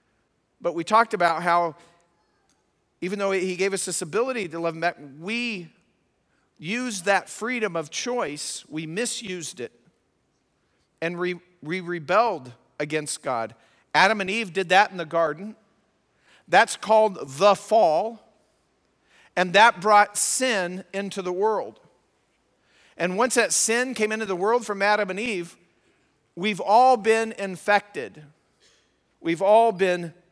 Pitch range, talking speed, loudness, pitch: 170-220 Hz, 135 wpm, -23 LUFS, 190 Hz